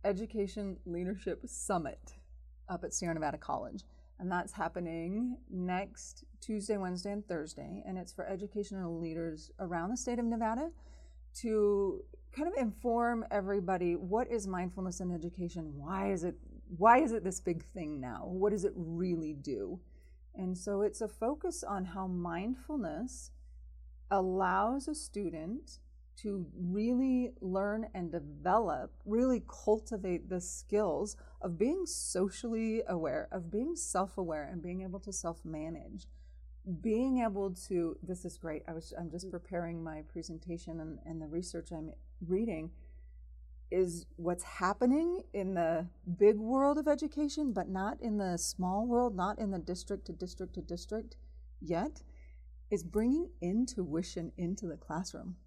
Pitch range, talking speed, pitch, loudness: 165-210 Hz, 145 wpm, 185 Hz, -36 LUFS